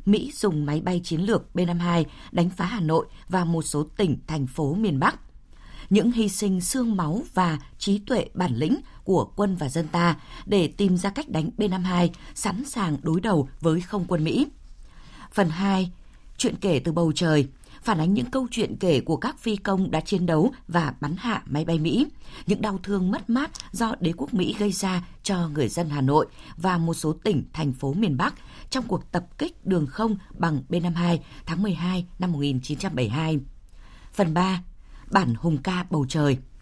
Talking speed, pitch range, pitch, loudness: 190 wpm, 160-205 Hz, 175 Hz, -25 LUFS